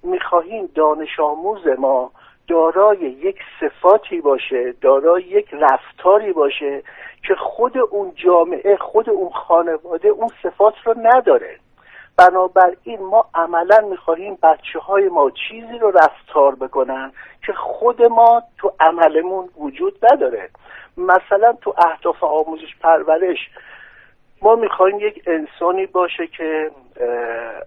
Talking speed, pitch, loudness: 115 wpm, 195 Hz, -16 LUFS